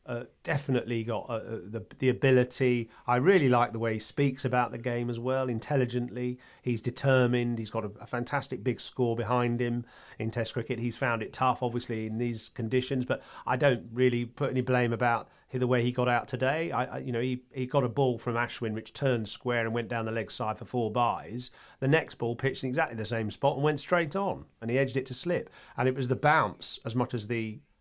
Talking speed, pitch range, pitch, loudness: 230 wpm, 120-130 Hz, 125 Hz, -30 LUFS